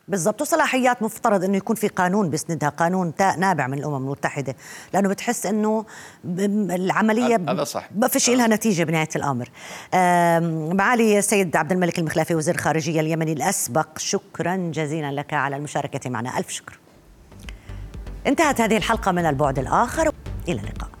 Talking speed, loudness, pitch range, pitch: 145 wpm, -22 LUFS, 150-215 Hz, 175 Hz